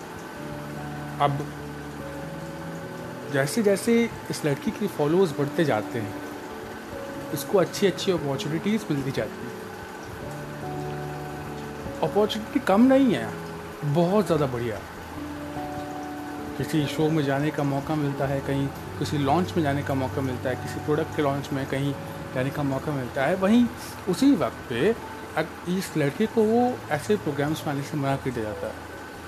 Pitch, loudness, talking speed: 140 Hz, -26 LUFS, 145 wpm